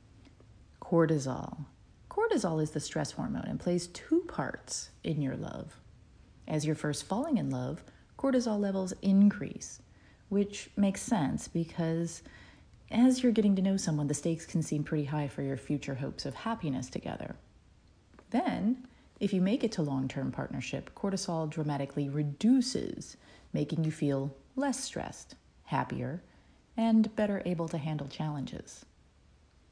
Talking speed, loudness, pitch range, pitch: 140 wpm, -32 LUFS, 145-210 Hz, 165 Hz